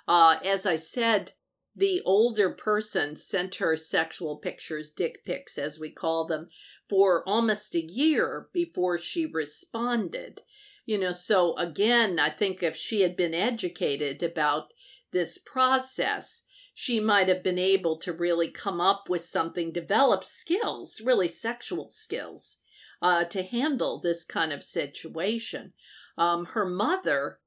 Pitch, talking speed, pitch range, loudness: 185 Hz, 140 wpm, 170-225 Hz, -27 LUFS